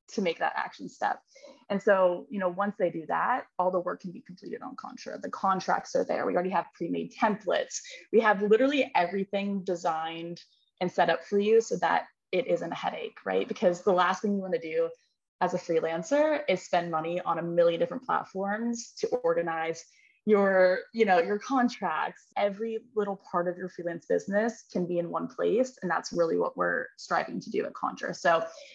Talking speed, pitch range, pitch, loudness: 200 wpm, 180-240 Hz, 200 Hz, -29 LUFS